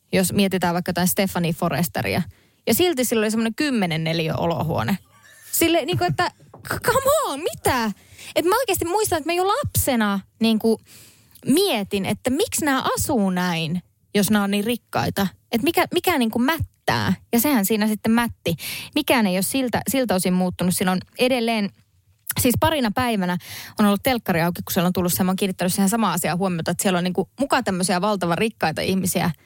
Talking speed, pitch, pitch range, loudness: 185 wpm, 205 Hz, 180-250 Hz, -21 LUFS